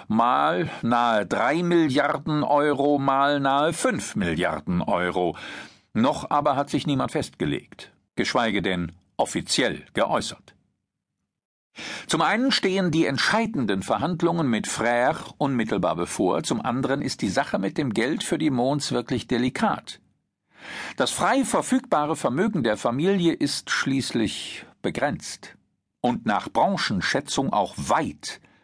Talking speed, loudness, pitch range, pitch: 120 wpm, -24 LUFS, 120-175 Hz, 145 Hz